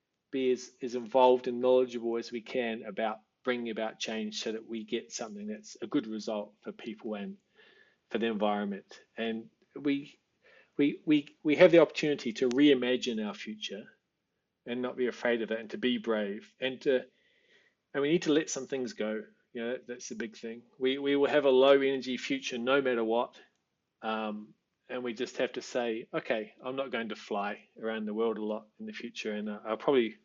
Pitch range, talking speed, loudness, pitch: 110-135 Hz, 200 wpm, -31 LUFS, 120 Hz